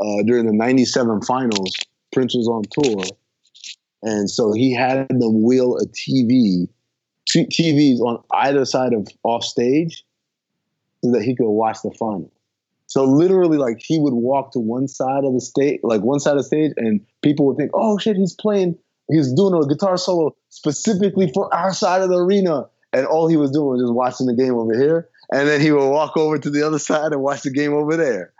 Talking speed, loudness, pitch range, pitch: 210 wpm, -18 LUFS, 120-160 Hz, 140 Hz